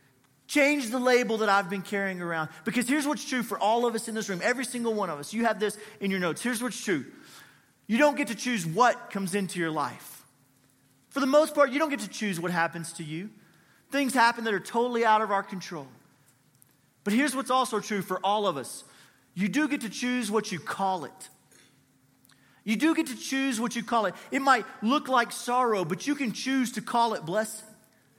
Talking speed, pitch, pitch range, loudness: 225 wpm, 215 Hz, 180-250 Hz, -27 LUFS